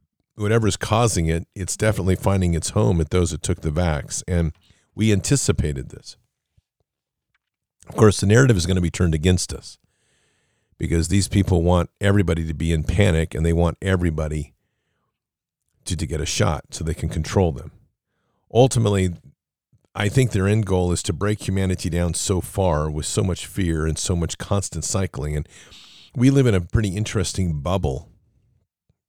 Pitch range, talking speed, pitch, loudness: 80-100 Hz, 170 wpm, 90 Hz, -21 LUFS